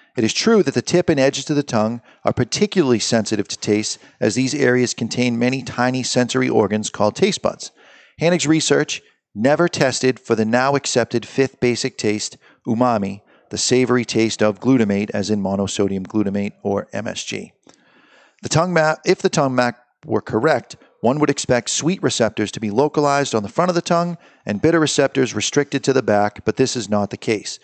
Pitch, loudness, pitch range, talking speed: 125 Hz, -19 LUFS, 105-140 Hz, 185 wpm